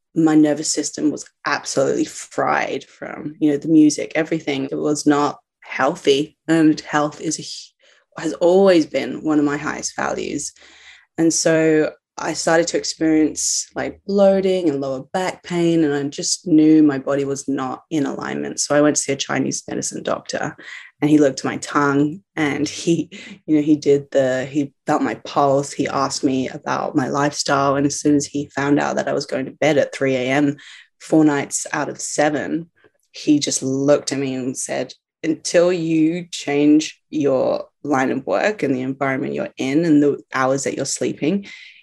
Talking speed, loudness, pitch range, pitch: 185 wpm, -19 LUFS, 140-160 Hz, 150 Hz